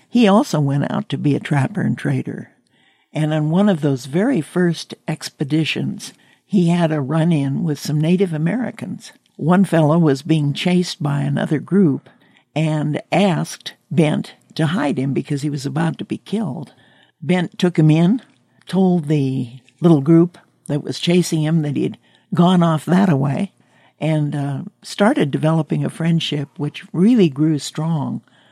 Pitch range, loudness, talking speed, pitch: 145-180 Hz, -18 LUFS, 160 wpm, 160 Hz